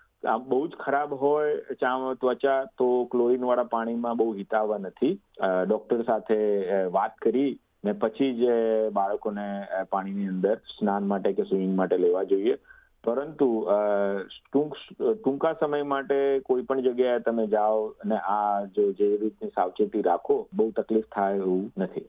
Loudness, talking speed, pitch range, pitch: -26 LUFS, 140 wpm, 100-135 Hz, 115 Hz